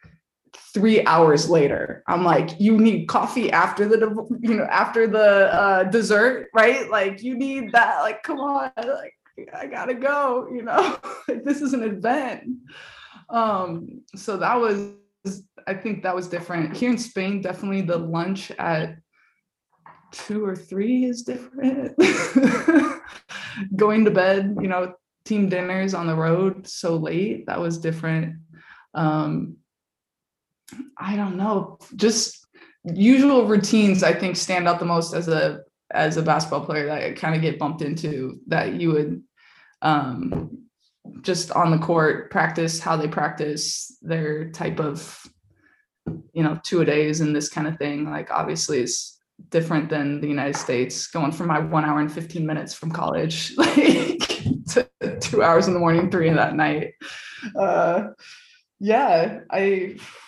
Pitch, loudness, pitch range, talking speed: 190 Hz, -22 LUFS, 165-230 Hz, 155 wpm